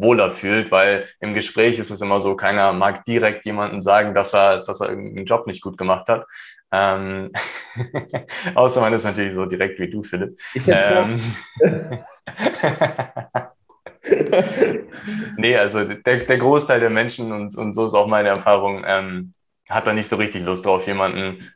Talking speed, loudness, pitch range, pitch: 160 wpm, -19 LUFS, 95-115 Hz, 105 Hz